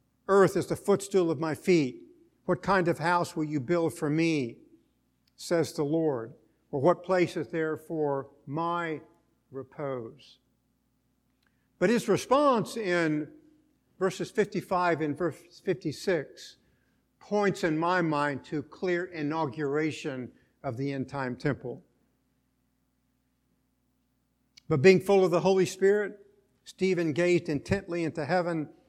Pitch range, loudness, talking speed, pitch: 145-185 Hz, -28 LUFS, 125 wpm, 165 Hz